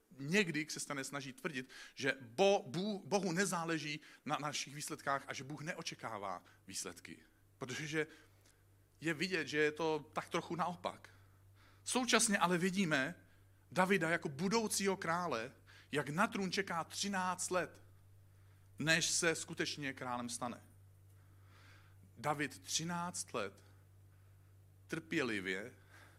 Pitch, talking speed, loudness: 135 Hz, 110 wpm, -38 LUFS